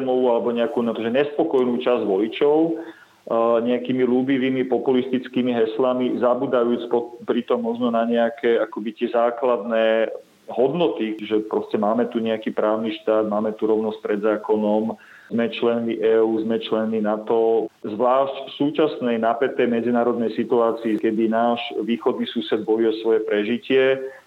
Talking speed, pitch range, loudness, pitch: 125 wpm, 110-125 Hz, -21 LUFS, 115 Hz